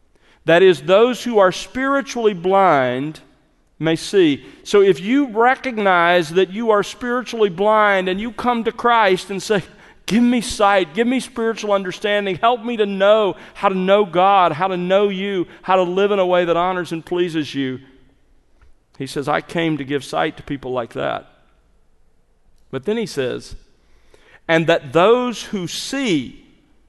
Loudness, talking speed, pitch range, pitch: -18 LUFS, 165 wpm, 165-225 Hz, 195 Hz